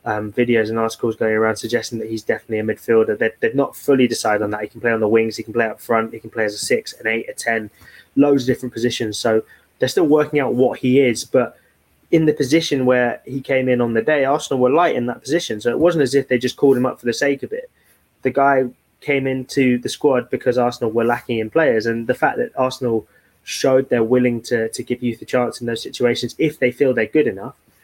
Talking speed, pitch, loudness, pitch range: 255 wpm, 120 Hz, -19 LUFS, 115-135 Hz